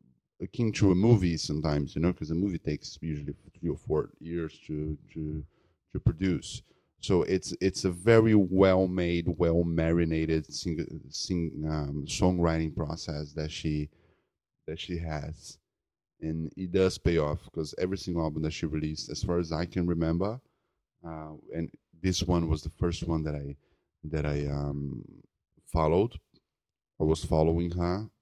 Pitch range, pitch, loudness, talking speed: 80-90 Hz, 85 Hz, -29 LUFS, 160 wpm